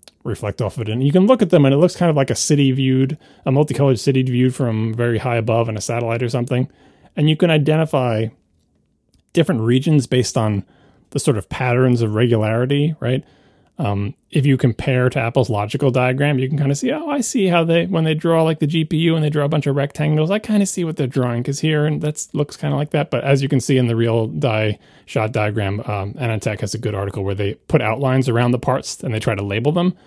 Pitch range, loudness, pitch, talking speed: 115-150 Hz, -18 LUFS, 130 Hz, 245 wpm